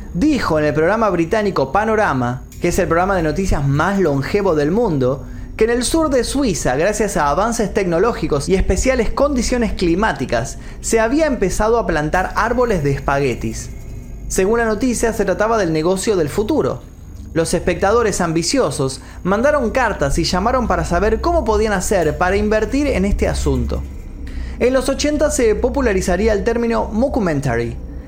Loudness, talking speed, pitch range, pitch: -17 LUFS, 155 wpm, 145-225 Hz, 190 Hz